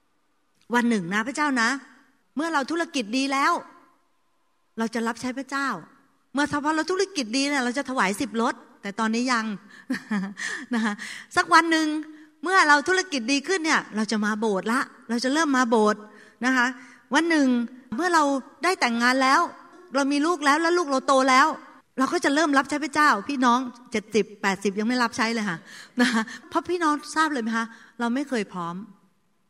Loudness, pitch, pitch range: -23 LUFS, 265 Hz, 230-305 Hz